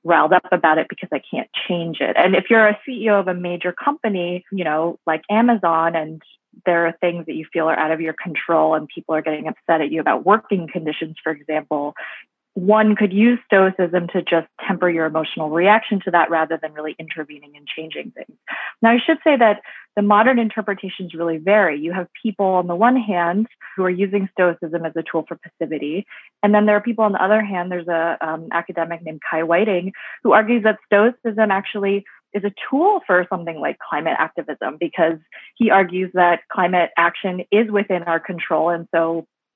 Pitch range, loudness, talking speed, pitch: 165-210 Hz, -19 LUFS, 200 wpm, 180 Hz